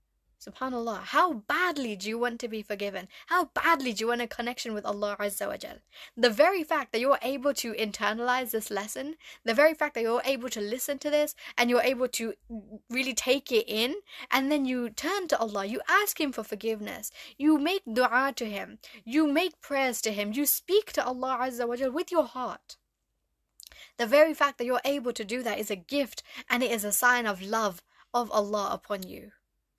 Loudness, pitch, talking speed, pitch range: -28 LUFS, 245 Hz, 205 wpm, 220-290 Hz